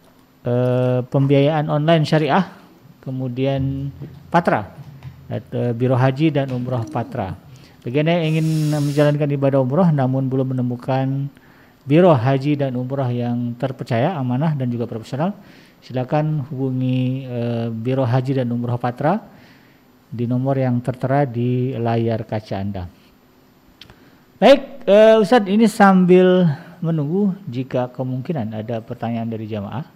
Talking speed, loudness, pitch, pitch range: 110 wpm, -19 LUFS, 135 Hz, 125-150 Hz